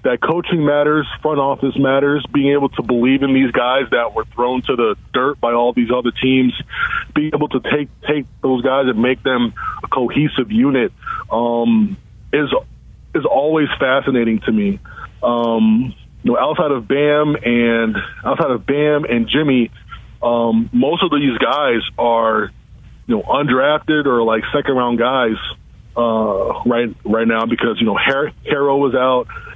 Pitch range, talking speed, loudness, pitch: 120-150 Hz, 165 wpm, -16 LUFS, 130 Hz